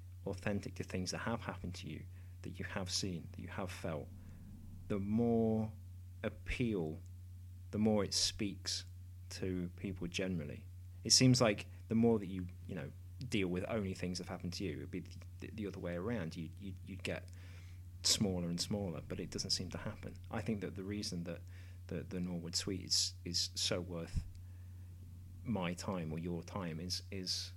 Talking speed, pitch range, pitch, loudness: 185 wpm, 90-100 Hz, 90 Hz, -38 LUFS